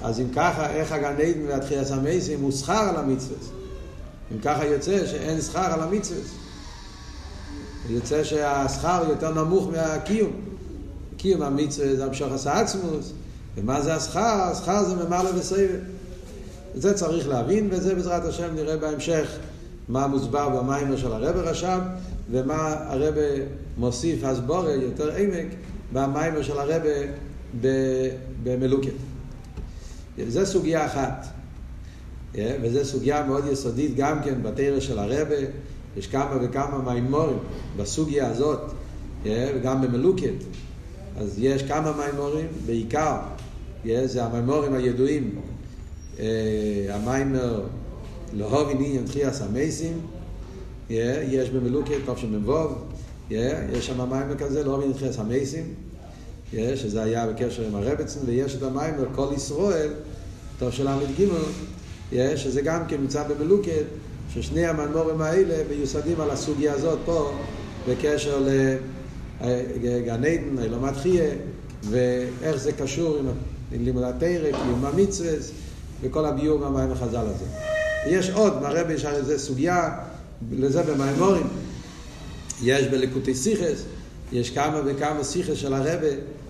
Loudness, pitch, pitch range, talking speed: -25 LUFS, 140 Hz, 125-155 Hz, 125 wpm